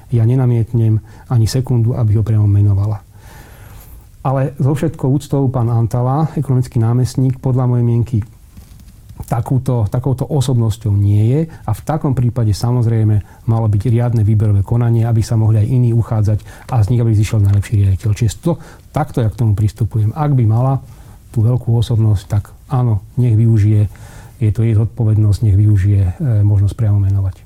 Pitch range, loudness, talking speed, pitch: 105-125 Hz, -15 LUFS, 160 wpm, 115 Hz